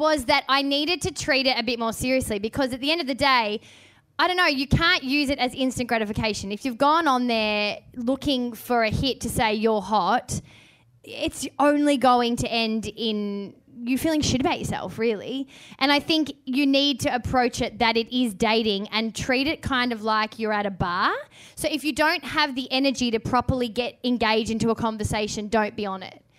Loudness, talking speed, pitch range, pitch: -23 LUFS, 210 wpm, 220-275 Hz, 245 Hz